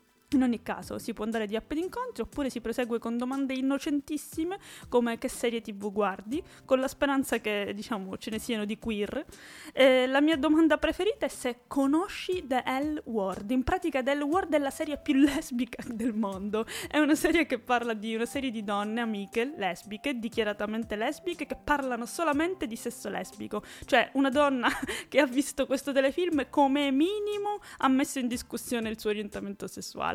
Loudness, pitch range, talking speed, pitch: -29 LUFS, 230-295 Hz, 180 wpm, 260 Hz